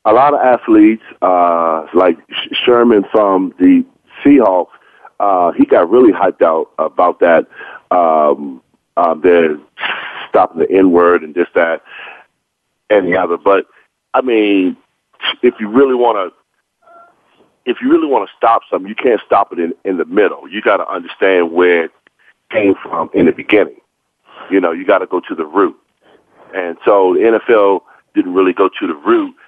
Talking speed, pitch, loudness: 175 wpm, 125 Hz, -13 LUFS